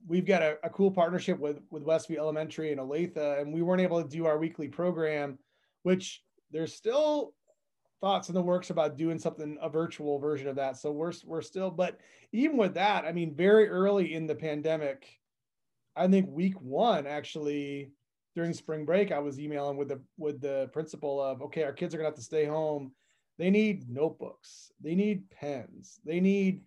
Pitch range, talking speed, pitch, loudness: 145-185 Hz, 190 wpm, 160 Hz, -31 LUFS